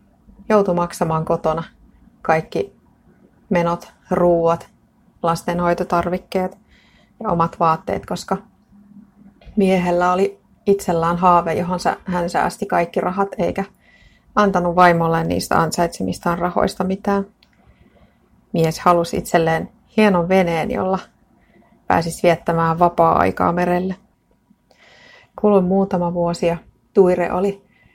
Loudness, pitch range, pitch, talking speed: -19 LUFS, 170-195 Hz, 180 Hz, 90 wpm